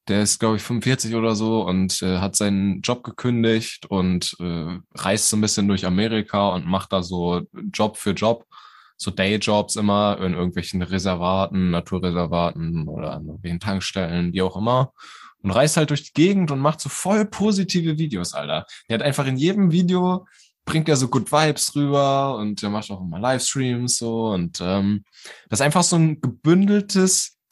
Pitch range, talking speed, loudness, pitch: 95-145 Hz, 180 wpm, -21 LUFS, 110 Hz